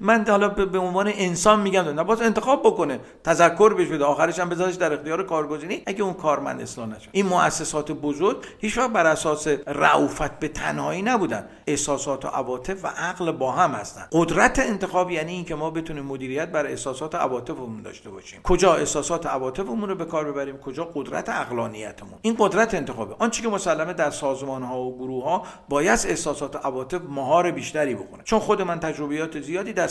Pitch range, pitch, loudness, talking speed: 145-190 Hz, 165 Hz, -23 LUFS, 185 wpm